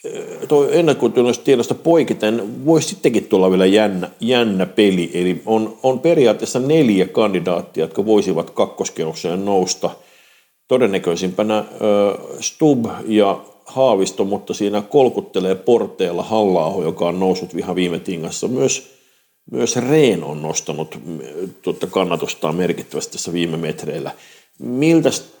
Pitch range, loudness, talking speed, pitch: 95-130 Hz, -17 LUFS, 115 wpm, 105 Hz